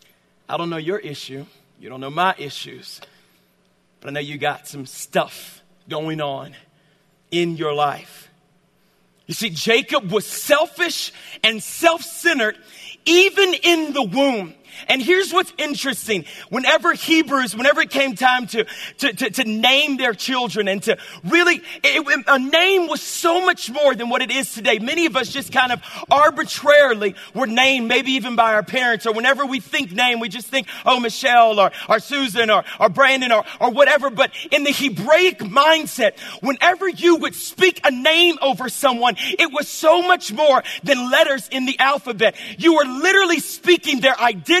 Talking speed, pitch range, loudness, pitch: 175 wpm, 215-310 Hz, -17 LUFS, 265 Hz